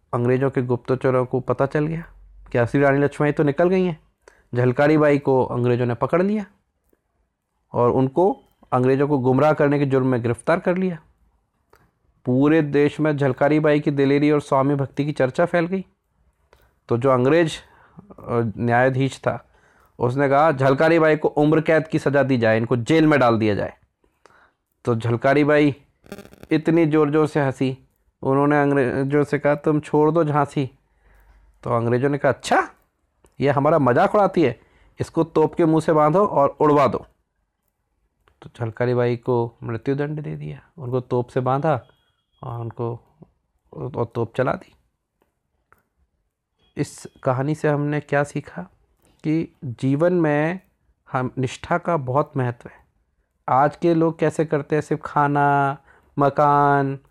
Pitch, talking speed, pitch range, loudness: 140 Hz, 155 wpm, 125-155 Hz, -20 LUFS